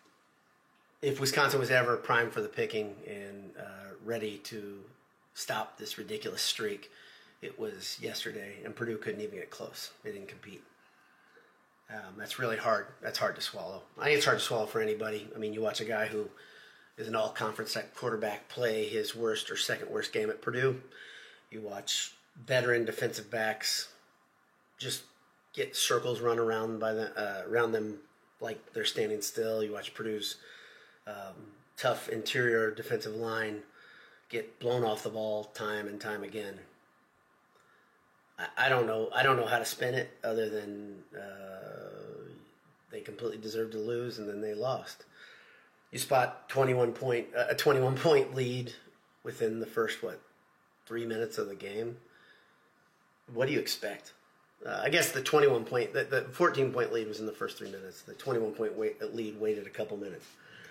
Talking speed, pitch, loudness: 165 wpm, 115 Hz, -33 LUFS